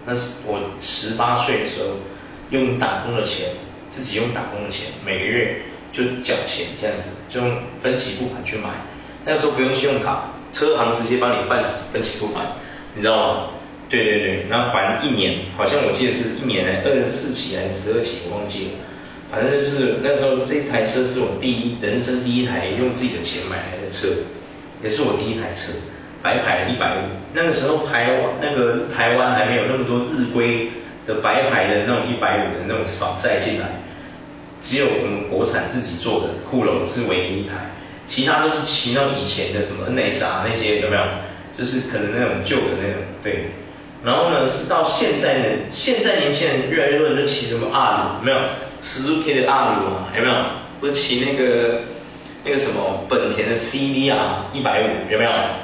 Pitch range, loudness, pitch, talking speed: 115-135 Hz, -20 LUFS, 125 Hz, 290 characters per minute